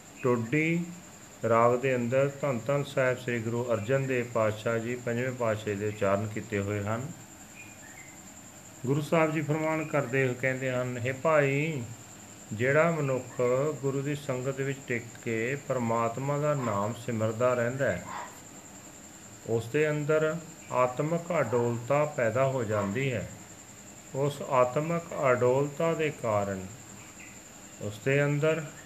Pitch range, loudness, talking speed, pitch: 110-145 Hz, -29 LUFS, 125 wpm, 125 Hz